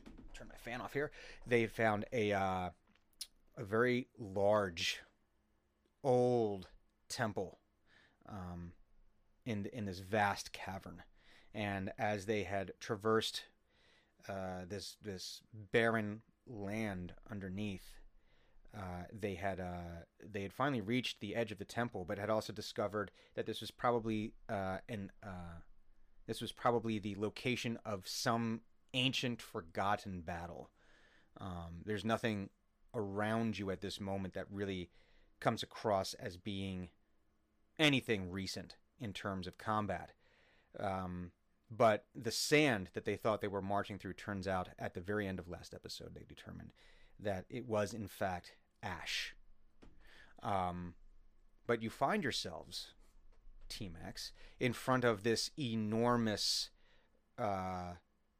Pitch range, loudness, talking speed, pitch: 95-110 Hz, -39 LUFS, 130 wpm, 105 Hz